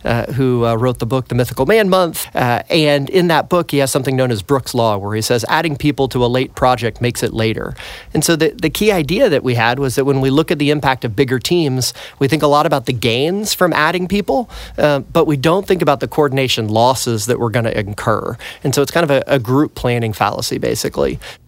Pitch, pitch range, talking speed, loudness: 135 Hz, 120-155 Hz, 250 wpm, -15 LUFS